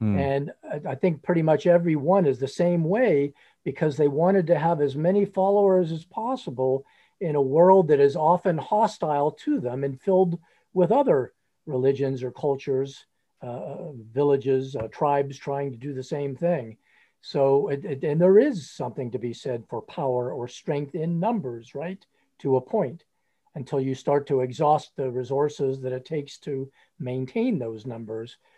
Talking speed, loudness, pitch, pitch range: 170 wpm, -24 LUFS, 145 Hz, 135-175 Hz